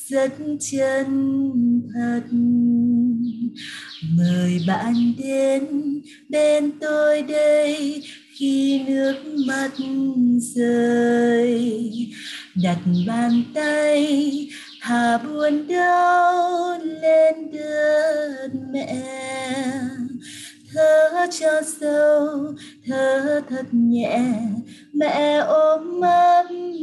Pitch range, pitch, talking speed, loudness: 240-300 Hz, 275 Hz, 70 wpm, -20 LUFS